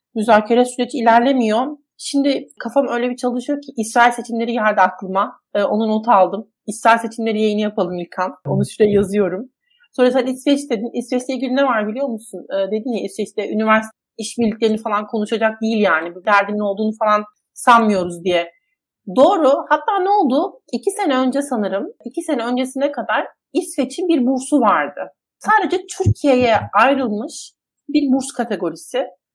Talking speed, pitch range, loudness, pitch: 150 wpm, 210-270 Hz, -18 LUFS, 235 Hz